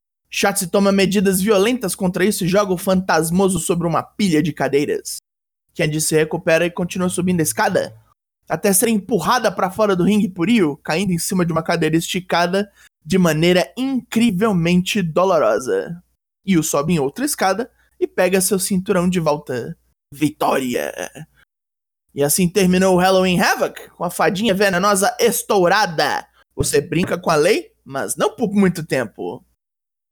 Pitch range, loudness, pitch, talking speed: 170-205 Hz, -18 LUFS, 185 Hz, 150 wpm